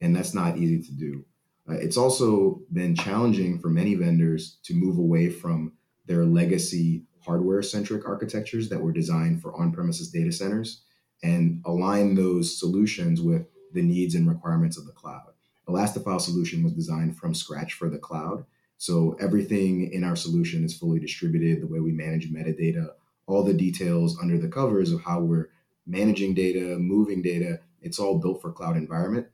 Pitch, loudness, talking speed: 100 Hz, -25 LUFS, 170 wpm